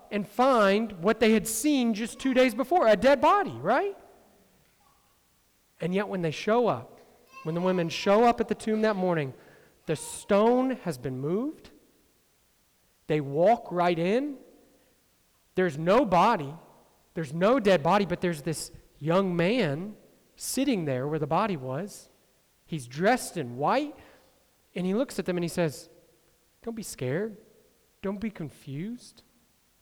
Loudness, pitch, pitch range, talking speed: -27 LUFS, 195 Hz, 165-235 Hz, 150 wpm